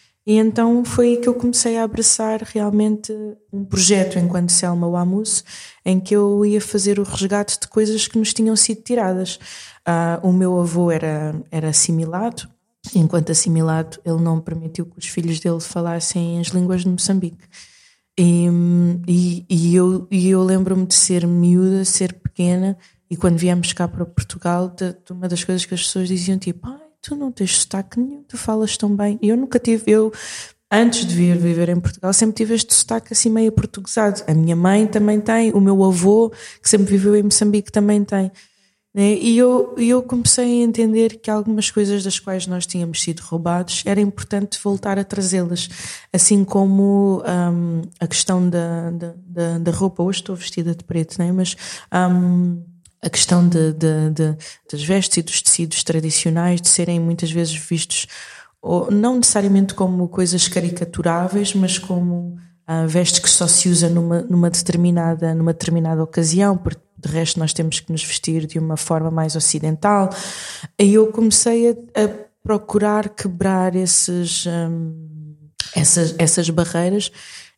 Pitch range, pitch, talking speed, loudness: 170-205 Hz, 185 Hz, 170 wpm, -17 LUFS